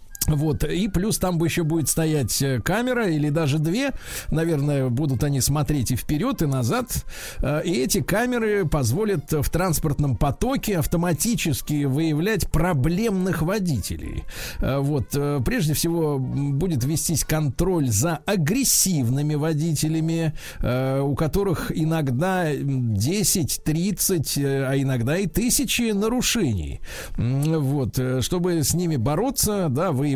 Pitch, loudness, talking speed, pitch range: 155 Hz, -23 LUFS, 115 wpm, 140-180 Hz